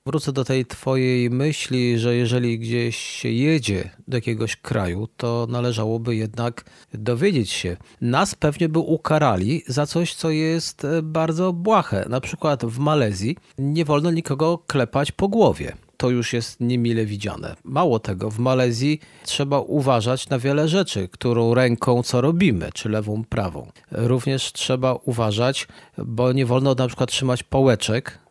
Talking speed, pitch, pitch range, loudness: 145 wpm, 125 Hz, 115-150 Hz, -21 LUFS